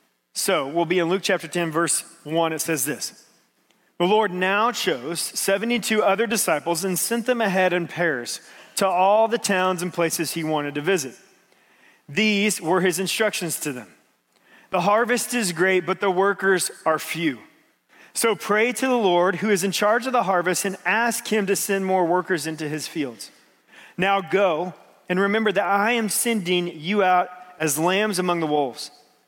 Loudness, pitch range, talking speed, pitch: -22 LUFS, 170-205 Hz, 180 wpm, 185 Hz